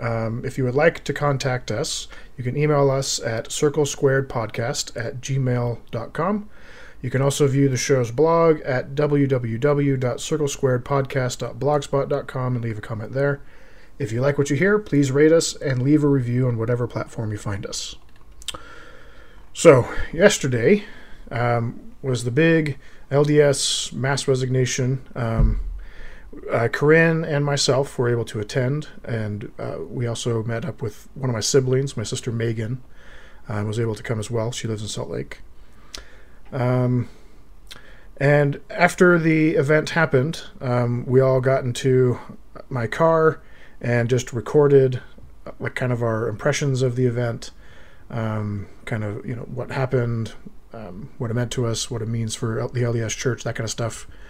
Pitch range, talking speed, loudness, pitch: 115-145 Hz, 155 wpm, -21 LUFS, 130 Hz